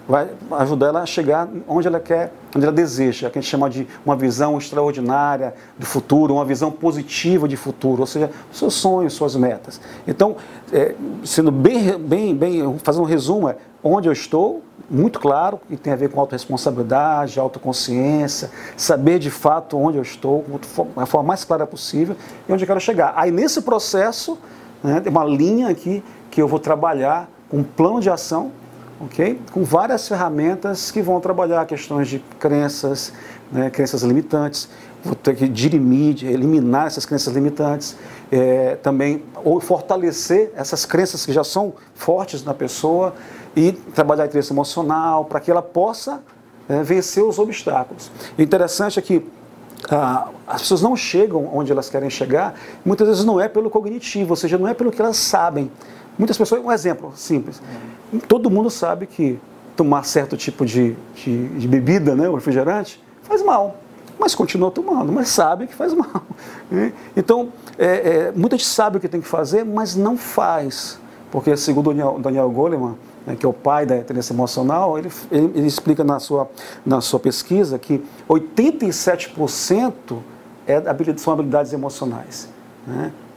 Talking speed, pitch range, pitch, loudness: 170 wpm, 140-195 Hz, 155 Hz, -19 LUFS